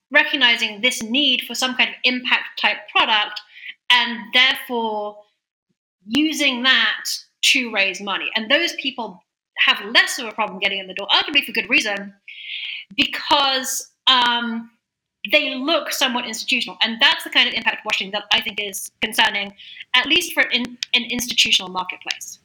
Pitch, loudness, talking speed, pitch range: 245 Hz, -18 LUFS, 160 wpm, 215-270 Hz